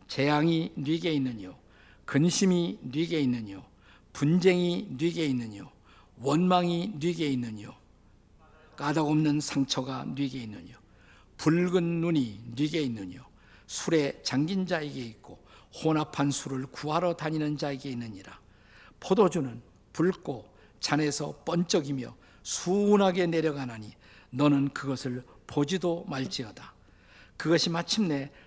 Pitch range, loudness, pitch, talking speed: 120-165 Hz, -29 LUFS, 140 Hz, 250 characters per minute